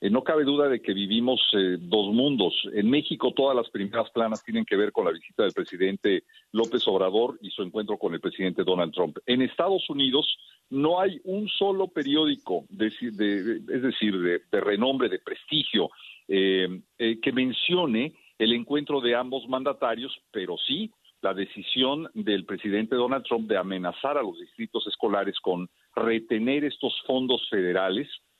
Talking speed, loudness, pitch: 165 wpm, -26 LUFS, 130 Hz